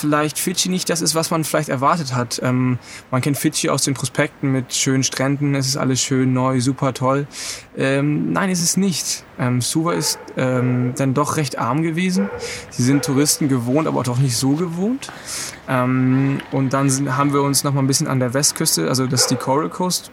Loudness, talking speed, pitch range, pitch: -19 LUFS, 210 wpm, 130-155 Hz, 140 Hz